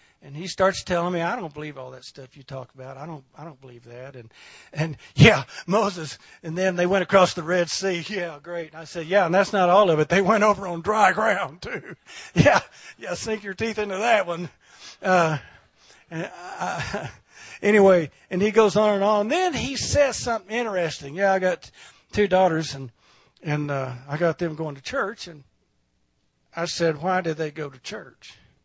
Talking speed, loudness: 205 wpm, -22 LUFS